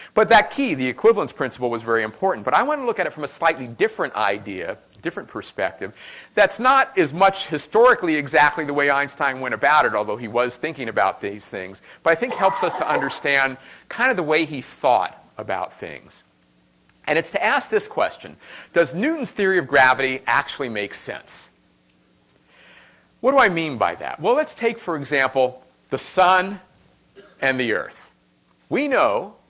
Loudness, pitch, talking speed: -20 LUFS, 155 Hz, 180 wpm